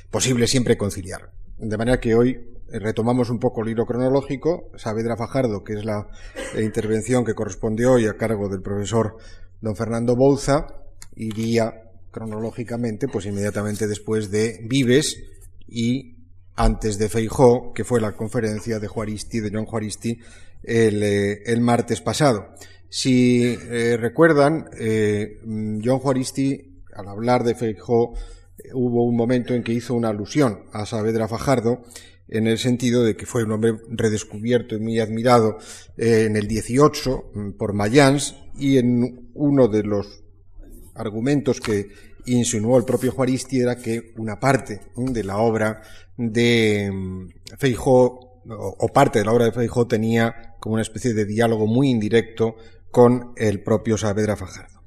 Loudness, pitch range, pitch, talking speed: -21 LUFS, 105-120 Hz, 115 Hz, 145 wpm